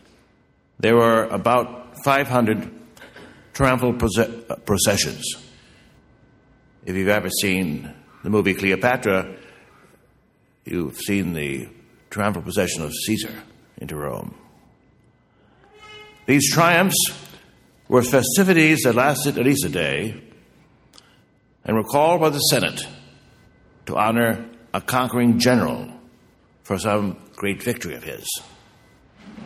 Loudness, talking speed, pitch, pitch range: -20 LUFS, 105 wpm, 115 Hz, 100-135 Hz